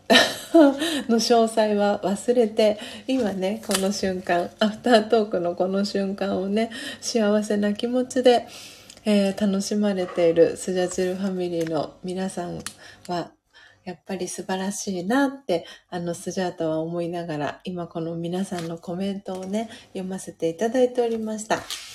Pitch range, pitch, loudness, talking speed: 180-225 Hz, 195 Hz, -24 LUFS, 300 characters per minute